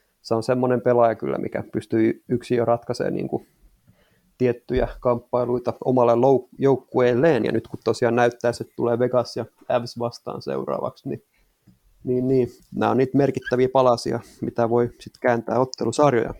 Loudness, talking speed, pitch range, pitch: -22 LUFS, 145 wpm, 115-125 Hz, 120 Hz